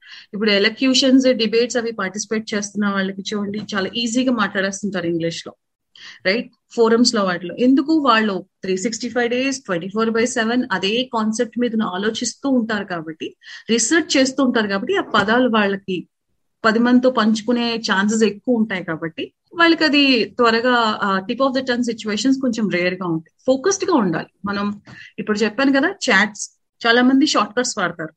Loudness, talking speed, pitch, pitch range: -18 LUFS, 155 wpm, 225 Hz, 200-250 Hz